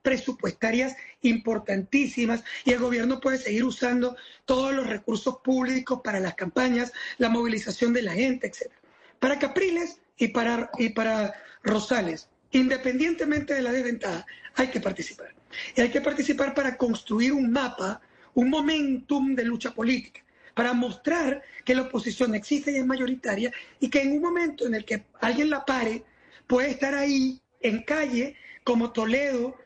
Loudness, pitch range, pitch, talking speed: -26 LUFS, 235-270 Hz, 255 Hz, 150 wpm